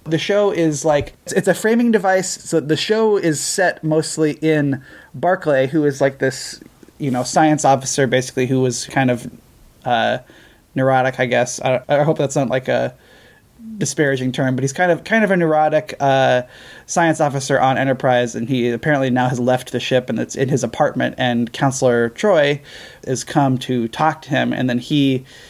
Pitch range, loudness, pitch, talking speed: 130-155 Hz, -18 LUFS, 135 Hz, 190 wpm